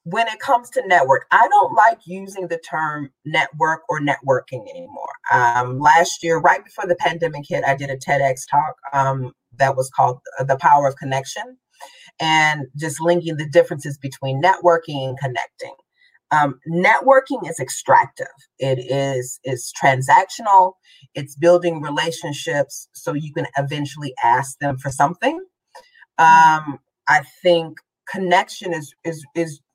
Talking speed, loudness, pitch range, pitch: 145 wpm, -18 LUFS, 140-185 Hz, 160 Hz